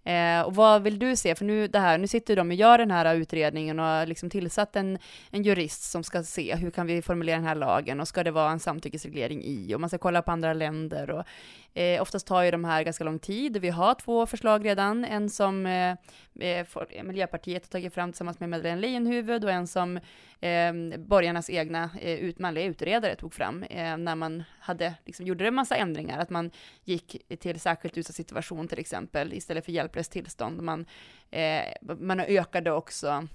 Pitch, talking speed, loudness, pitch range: 175 Hz, 200 wpm, -28 LUFS, 165-190 Hz